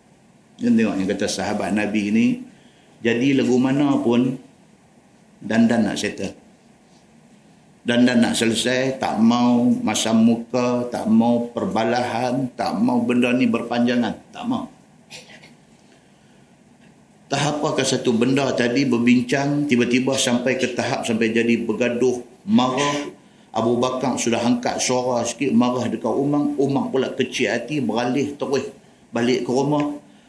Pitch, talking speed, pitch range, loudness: 125 Hz, 125 wpm, 120-145 Hz, -20 LUFS